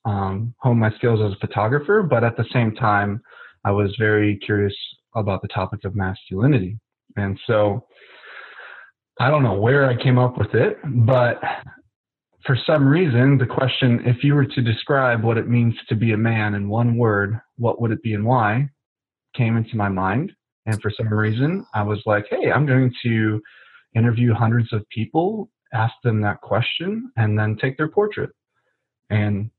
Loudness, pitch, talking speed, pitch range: -20 LUFS, 115 Hz, 180 wpm, 105-130 Hz